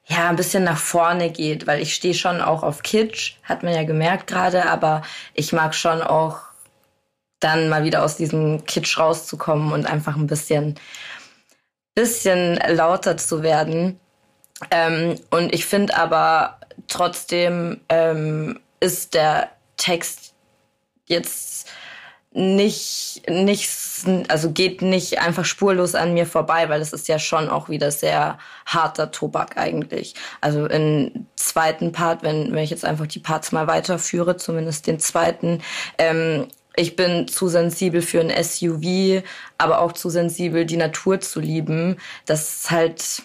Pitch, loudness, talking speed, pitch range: 165 Hz, -20 LUFS, 145 wpm, 160-180 Hz